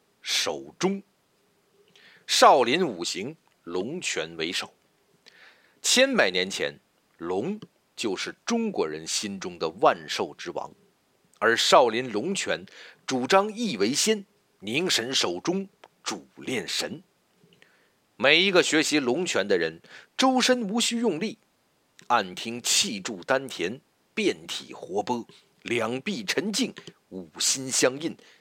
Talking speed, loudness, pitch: 165 characters per minute, -25 LUFS, 200 Hz